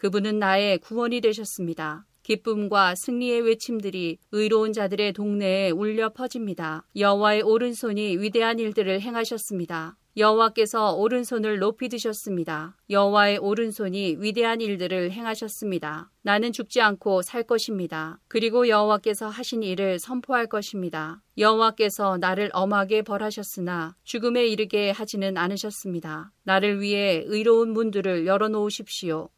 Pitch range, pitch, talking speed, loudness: 190-225 Hz, 210 Hz, 350 characters per minute, -24 LUFS